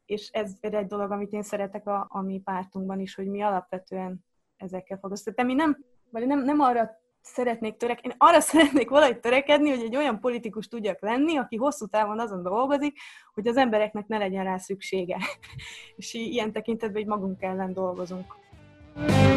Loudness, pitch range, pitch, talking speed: -26 LUFS, 195-250 Hz, 215 Hz, 175 wpm